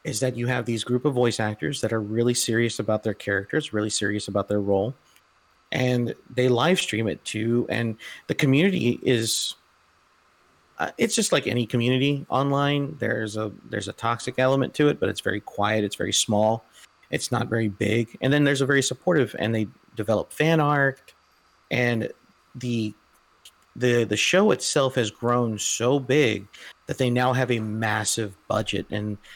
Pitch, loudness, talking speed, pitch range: 120 Hz, -24 LUFS, 175 wpm, 105-130 Hz